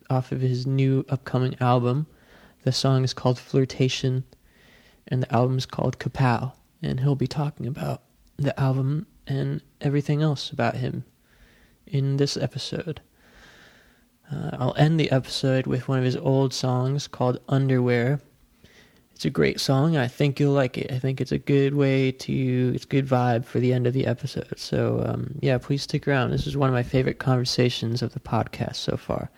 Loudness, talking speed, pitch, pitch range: -24 LUFS, 180 wpm, 130 Hz, 125-140 Hz